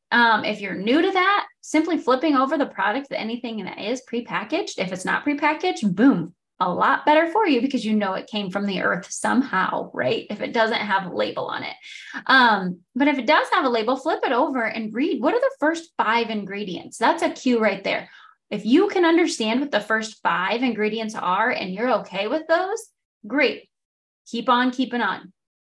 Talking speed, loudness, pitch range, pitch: 205 wpm, -22 LUFS, 215-310 Hz, 250 Hz